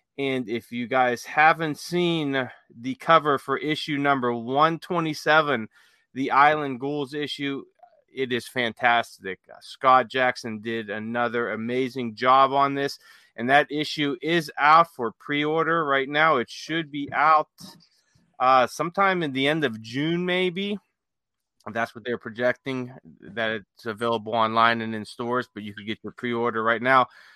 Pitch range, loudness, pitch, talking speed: 120-155 Hz, -23 LUFS, 130 Hz, 145 wpm